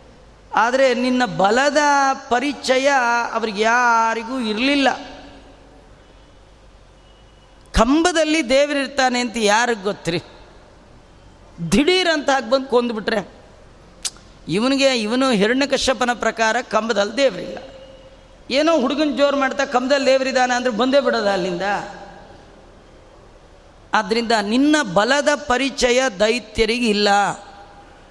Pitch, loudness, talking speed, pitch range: 250 Hz, -18 LUFS, 80 wpm, 225-275 Hz